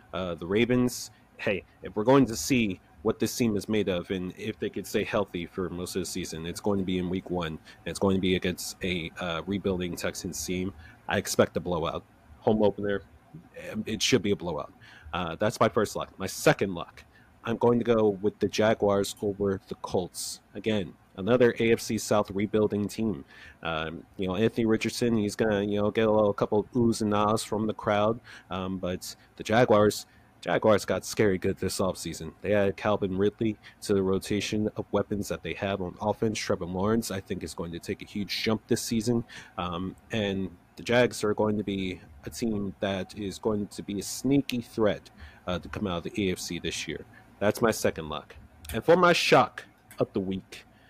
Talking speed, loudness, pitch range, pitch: 205 wpm, -28 LUFS, 95-110 Hz, 105 Hz